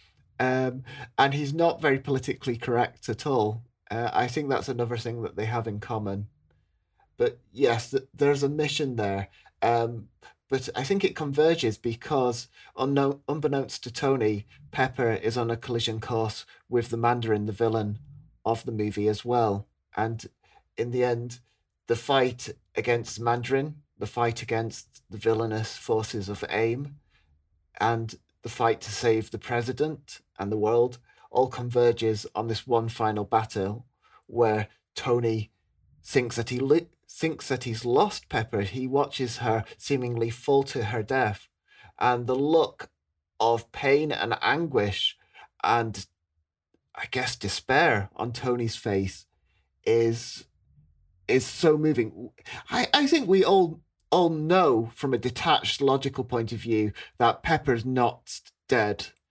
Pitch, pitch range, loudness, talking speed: 120 Hz, 110-135 Hz, -27 LUFS, 145 wpm